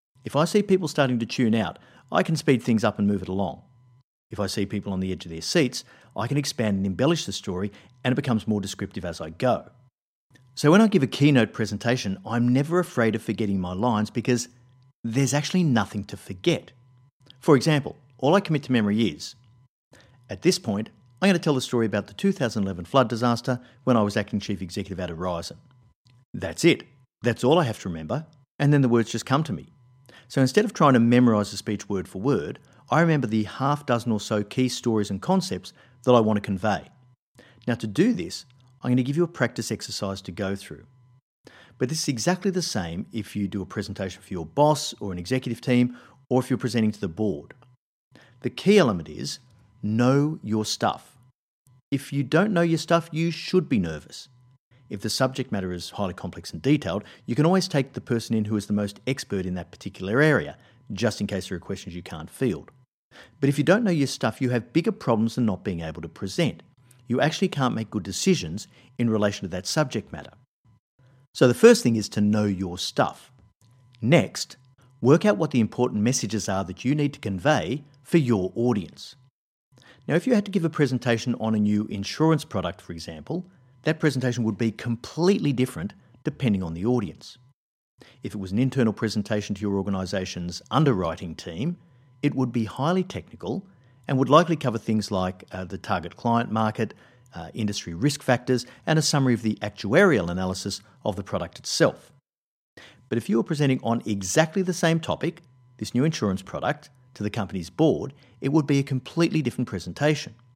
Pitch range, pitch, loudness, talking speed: 105-140 Hz, 125 Hz, -25 LUFS, 200 wpm